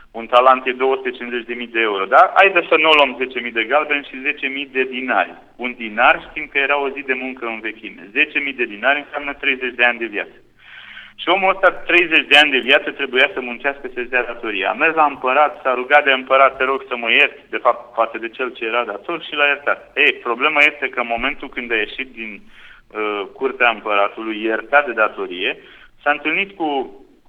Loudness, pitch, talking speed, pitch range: -17 LUFS, 135 Hz, 210 wpm, 120-150 Hz